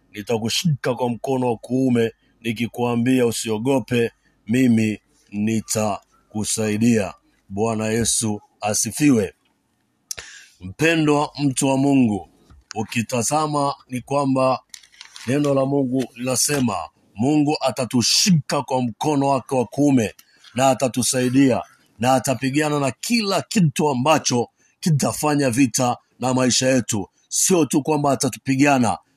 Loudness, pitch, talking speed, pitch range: -20 LUFS, 130 Hz, 95 wpm, 115-140 Hz